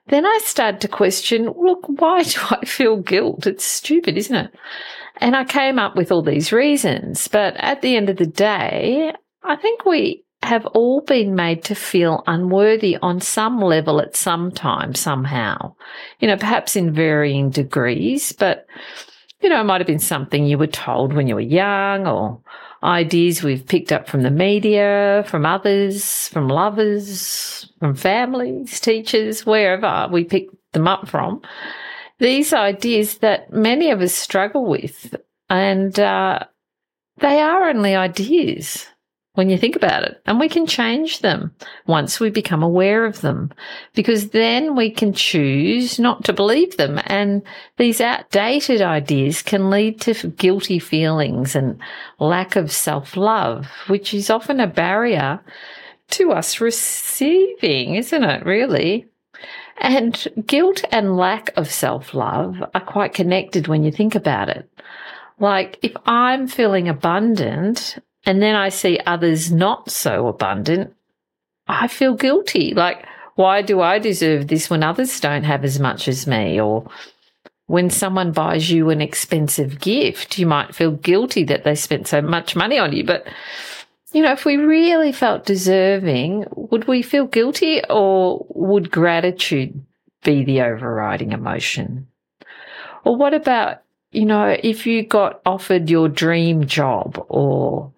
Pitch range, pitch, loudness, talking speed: 165-235 Hz, 195 Hz, -18 LUFS, 155 wpm